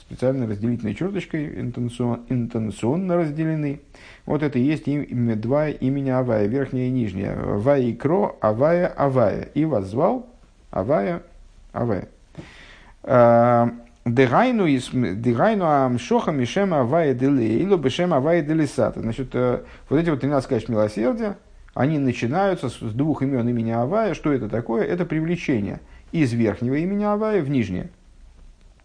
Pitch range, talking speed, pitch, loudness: 120-155 Hz, 120 wpm, 130 Hz, -22 LUFS